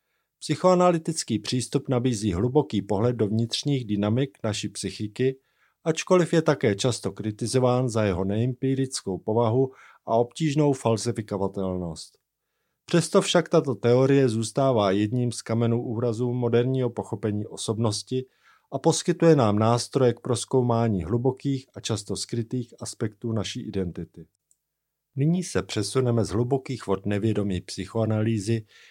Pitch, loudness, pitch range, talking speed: 120 Hz, -25 LUFS, 105-135 Hz, 115 wpm